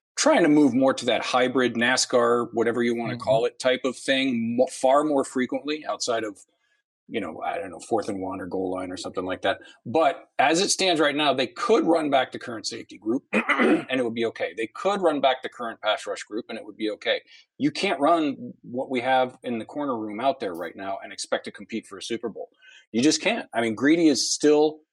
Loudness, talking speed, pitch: -24 LUFS, 240 wpm, 130 Hz